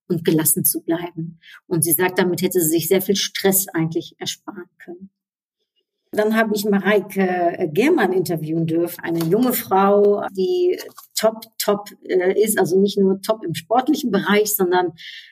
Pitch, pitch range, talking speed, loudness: 195 Hz, 175-210 Hz, 155 wpm, -19 LUFS